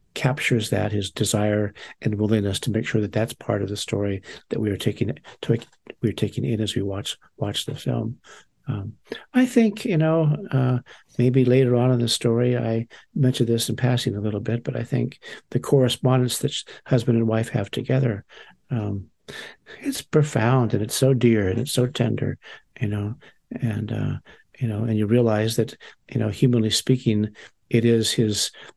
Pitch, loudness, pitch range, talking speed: 115 Hz, -23 LUFS, 110-130 Hz, 185 wpm